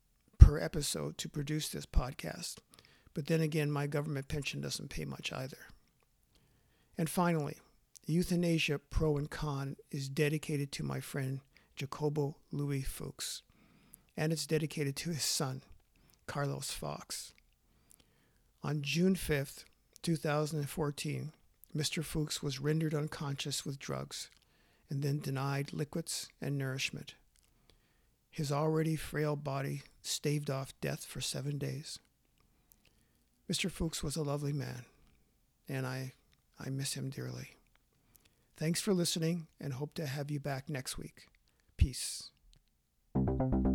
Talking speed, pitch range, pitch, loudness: 120 wpm, 135-155 Hz, 145 Hz, -36 LUFS